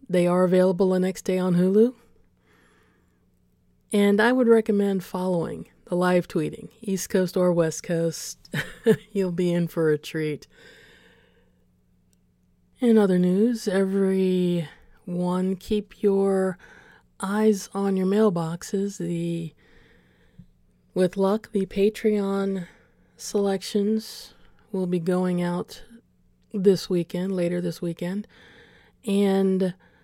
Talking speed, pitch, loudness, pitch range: 105 wpm, 185 Hz, -24 LUFS, 175-200 Hz